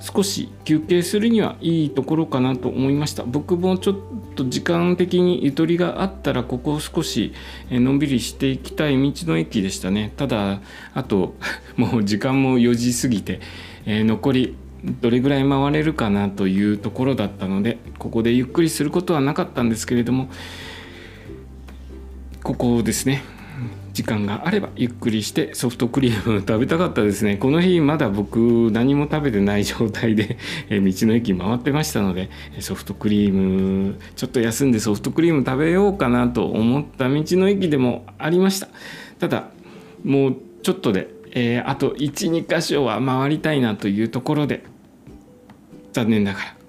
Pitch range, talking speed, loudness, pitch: 105-145 Hz, 330 characters per minute, -20 LUFS, 125 Hz